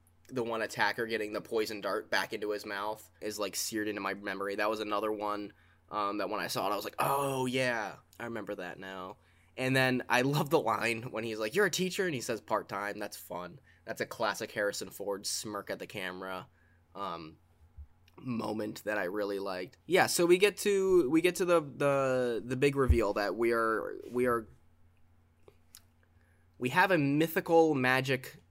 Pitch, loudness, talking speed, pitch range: 105 Hz, -32 LUFS, 195 wpm, 90-130 Hz